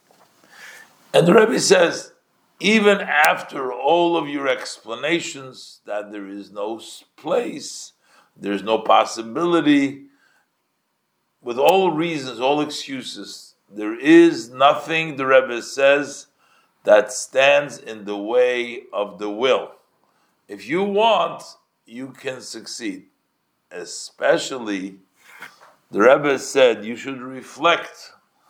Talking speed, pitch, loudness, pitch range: 105 wpm, 145 Hz, -19 LUFS, 120-175 Hz